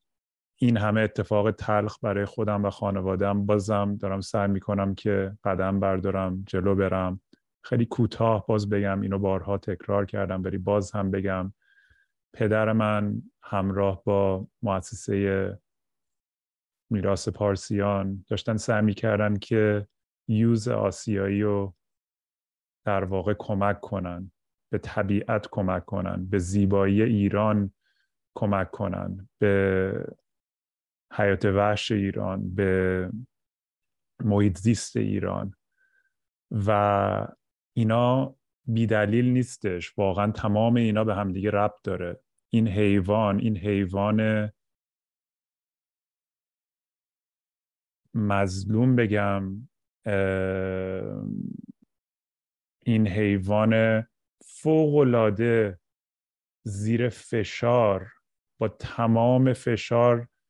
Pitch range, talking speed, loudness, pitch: 95-110 Hz, 90 wpm, -26 LUFS, 100 Hz